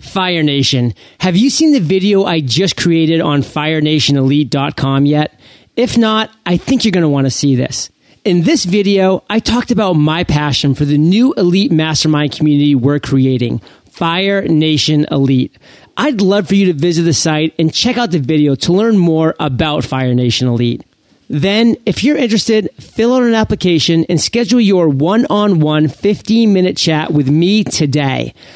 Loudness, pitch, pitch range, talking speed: -12 LUFS, 165 Hz, 145-205 Hz, 175 wpm